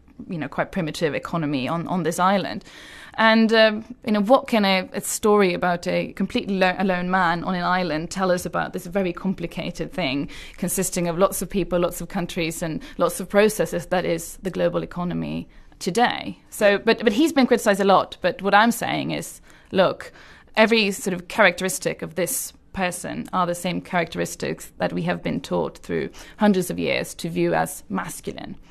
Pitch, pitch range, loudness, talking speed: 185 Hz, 170-200 Hz, -22 LUFS, 190 wpm